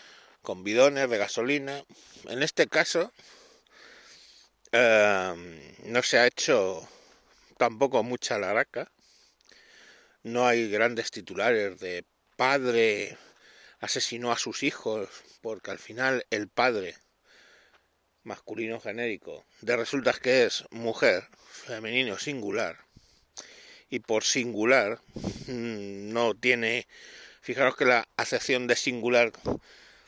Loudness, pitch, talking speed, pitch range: -27 LUFS, 120 Hz, 100 wpm, 110-125 Hz